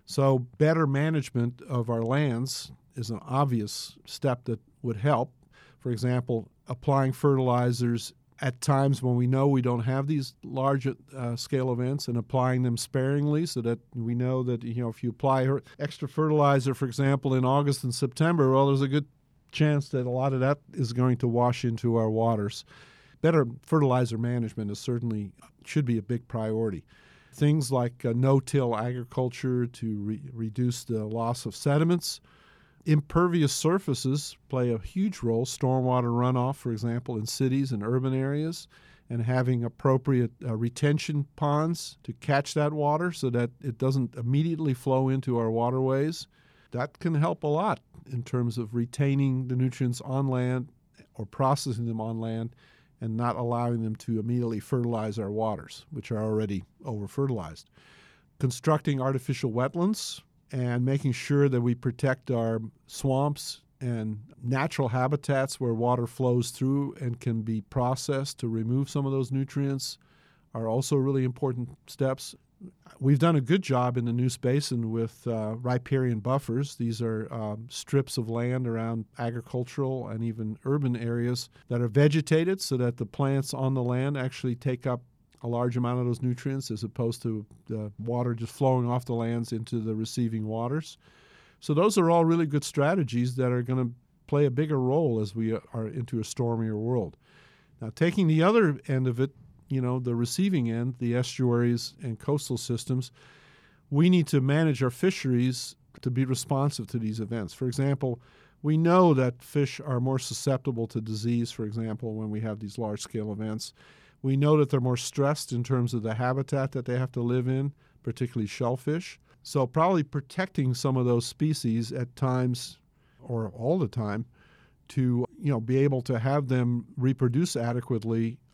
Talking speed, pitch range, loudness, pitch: 170 wpm, 120-140 Hz, -28 LUFS, 130 Hz